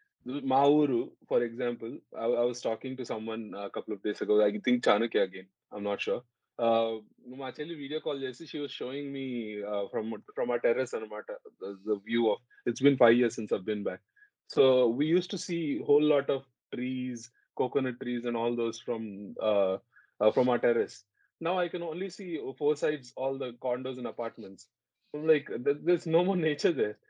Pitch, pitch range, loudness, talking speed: 130 Hz, 115-155 Hz, -30 LUFS, 190 wpm